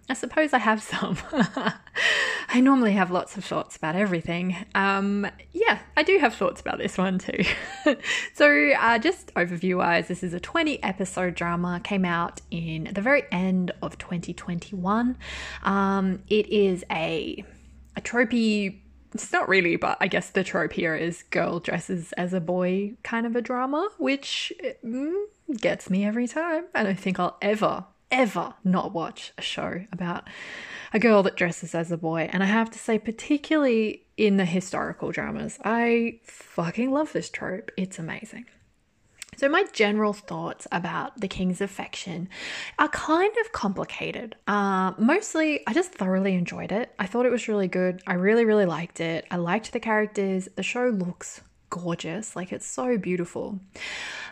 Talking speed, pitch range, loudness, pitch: 160 wpm, 185-255 Hz, -25 LUFS, 205 Hz